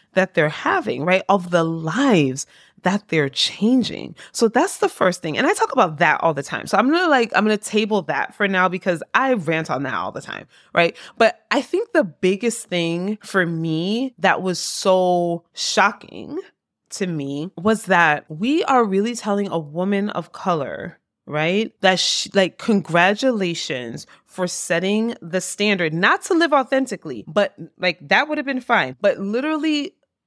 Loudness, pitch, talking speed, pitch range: -20 LUFS, 195 Hz, 180 wpm, 170-240 Hz